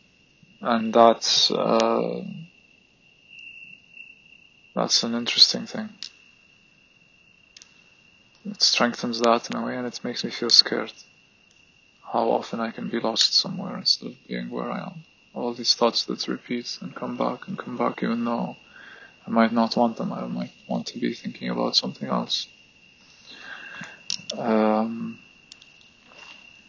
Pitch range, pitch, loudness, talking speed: 110-125 Hz, 115 Hz, -23 LUFS, 135 wpm